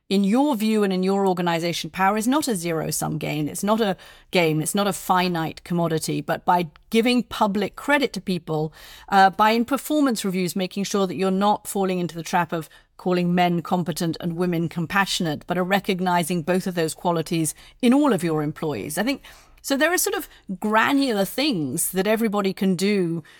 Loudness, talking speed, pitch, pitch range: -22 LUFS, 195 wpm, 190 Hz, 170-210 Hz